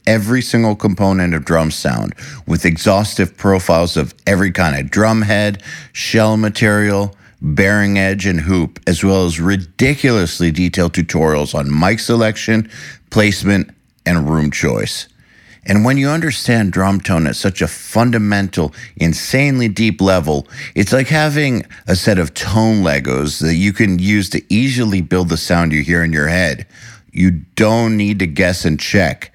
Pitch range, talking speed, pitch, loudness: 85-110 Hz, 155 wpm, 95 Hz, -14 LUFS